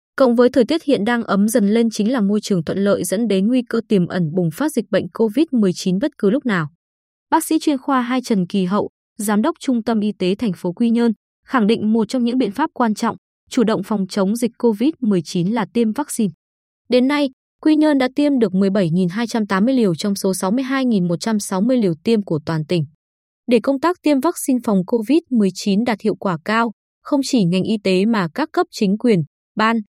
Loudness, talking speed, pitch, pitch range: -18 LUFS, 210 wpm, 225 Hz, 195-255 Hz